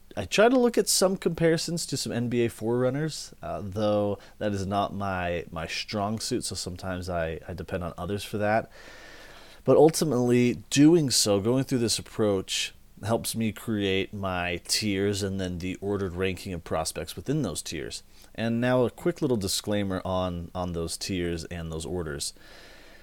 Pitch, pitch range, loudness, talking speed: 100 Hz, 95-120 Hz, -27 LUFS, 170 wpm